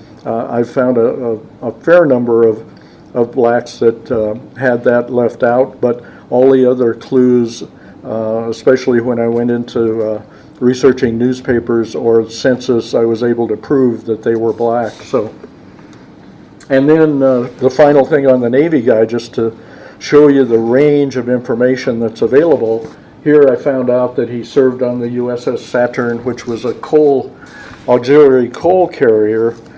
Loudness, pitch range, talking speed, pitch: -12 LUFS, 115-130 Hz, 165 wpm, 120 Hz